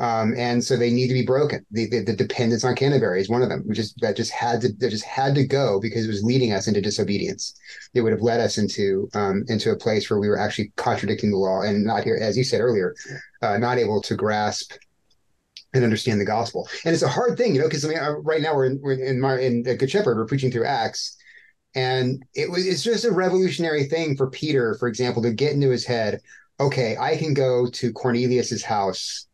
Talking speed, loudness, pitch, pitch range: 240 wpm, -22 LUFS, 125 Hz, 115-140 Hz